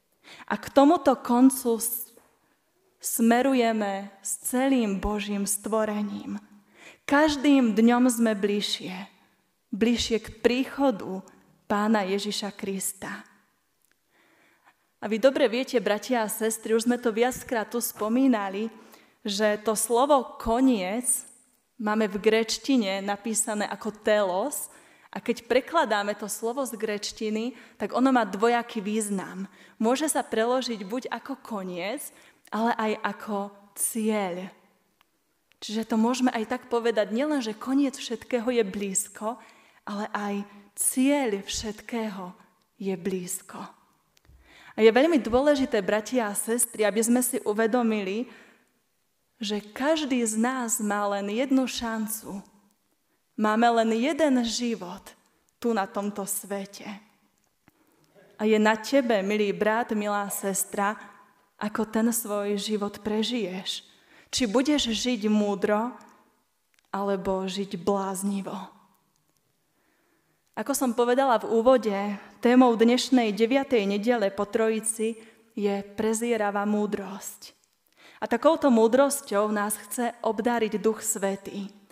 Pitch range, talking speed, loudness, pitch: 205-245 Hz, 110 wpm, -26 LUFS, 220 Hz